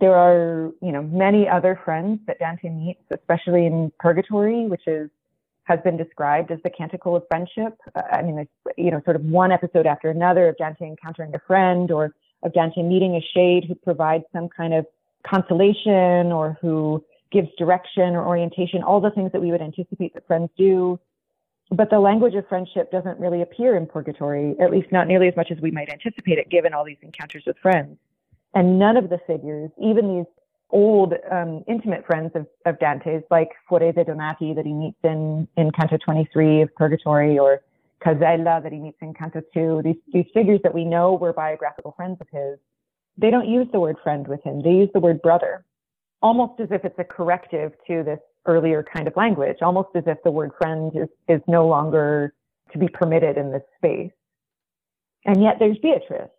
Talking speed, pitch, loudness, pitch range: 200 wpm, 170 Hz, -20 LUFS, 160-185 Hz